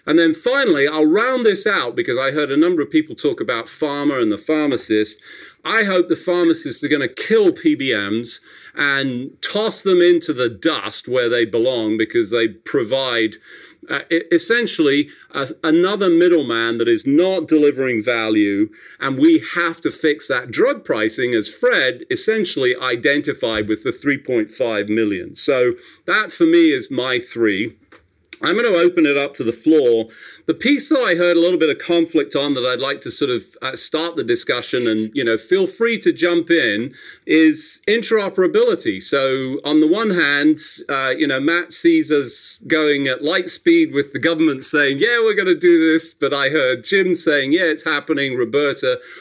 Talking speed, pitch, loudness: 180 wpm, 165 Hz, -17 LUFS